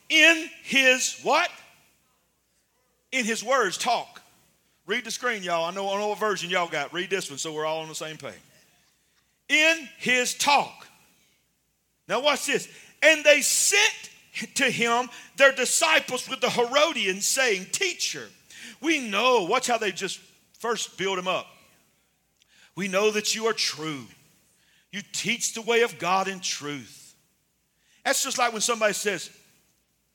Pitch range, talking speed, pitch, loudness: 190-265 Hz, 155 wpm, 225 Hz, -23 LUFS